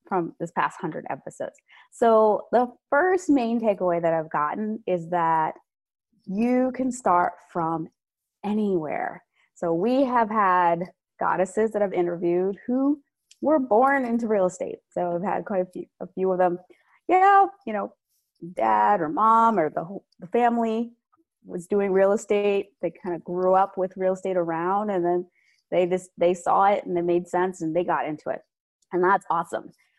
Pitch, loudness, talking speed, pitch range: 190 Hz, -24 LUFS, 175 wpm, 175-230 Hz